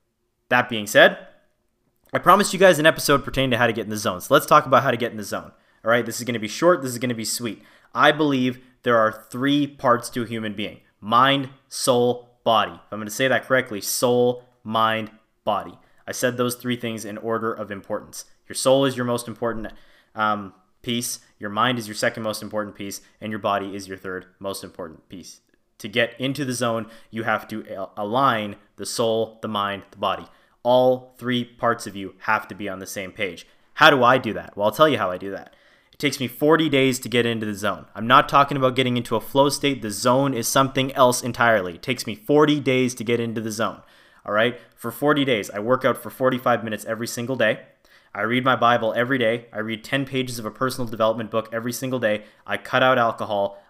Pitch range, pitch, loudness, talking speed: 110-130 Hz, 120 Hz, -21 LUFS, 235 wpm